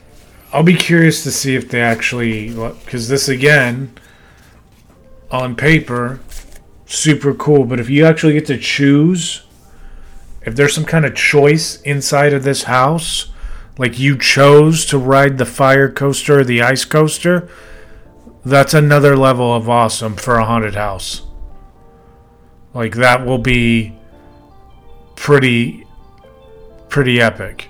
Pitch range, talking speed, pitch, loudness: 115-145 Hz, 130 wpm, 125 Hz, -13 LUFS